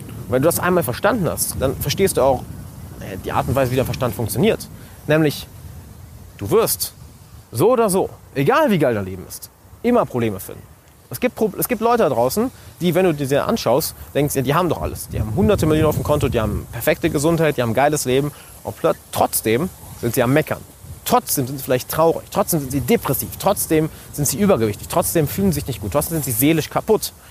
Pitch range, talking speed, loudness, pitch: 115-160 Hz, 215 wpm, -19 LUFS, 140 Hz